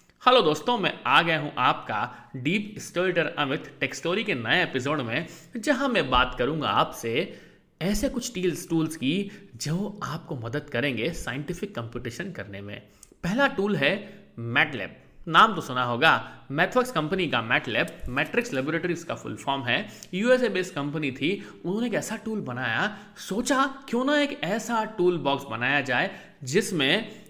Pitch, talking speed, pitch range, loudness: 175 Hz, 150 wpm, 140-210 Hz, -26 LUFS